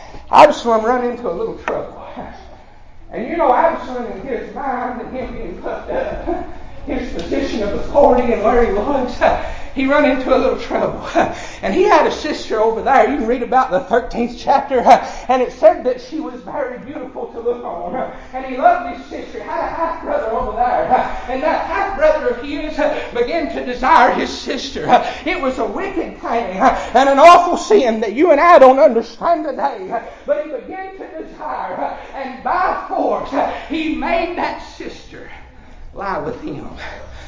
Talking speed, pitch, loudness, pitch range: 180 wpm, 285 Hz, -16 LUFS, 250-330 Hz